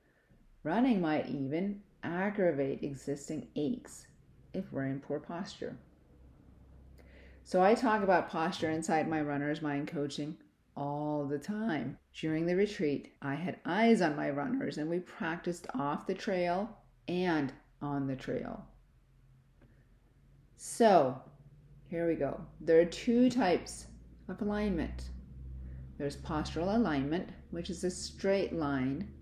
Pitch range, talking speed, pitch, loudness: 135-180 Hz, 125 wpm, 150 Hz, -33 LUFS